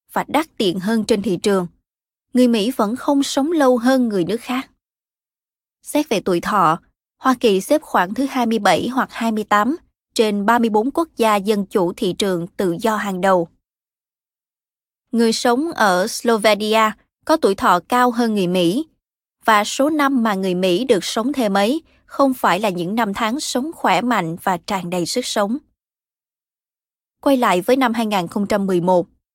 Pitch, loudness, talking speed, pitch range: 225 Hz, -18 LUFS, 165 wpm, 195-255 Hz